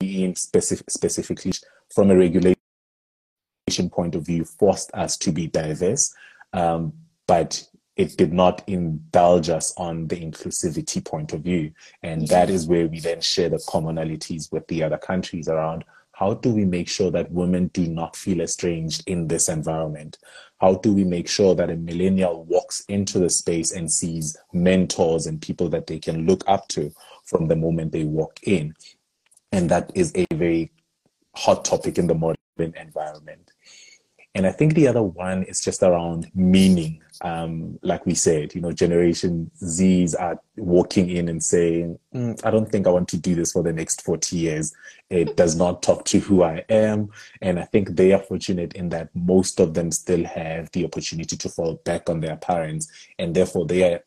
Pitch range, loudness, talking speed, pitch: 80-95 Hz, -22 LUFS, 180 wpm, 85 Hz